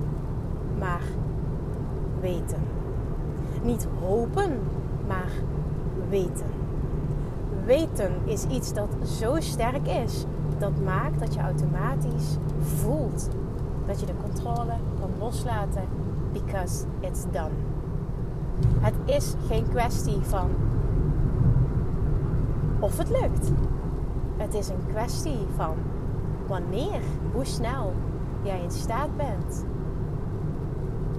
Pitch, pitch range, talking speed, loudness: 140 Hz, 130-145 Hz, 90 wpm, -28 LUFS